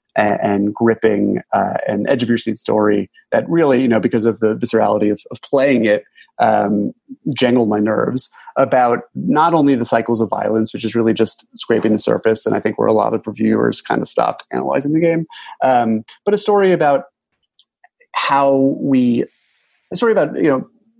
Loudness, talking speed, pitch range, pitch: -16 LUFS, 185 wpm, 110-165 Hz, 120 Hz